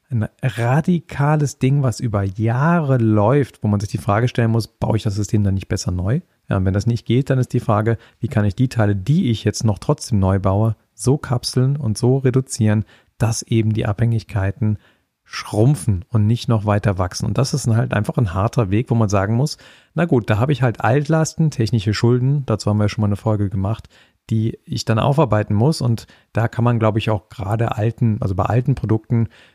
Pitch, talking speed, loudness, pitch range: 115 Hz, 215 wpm, -19 LUFS, 105-130 Hz